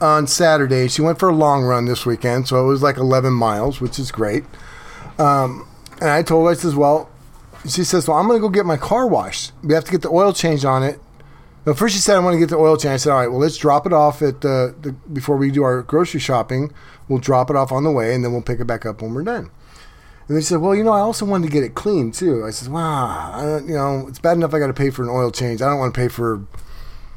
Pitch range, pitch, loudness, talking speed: 125-160 Hz, 140 Hz, -17 LUFS, 285 wpm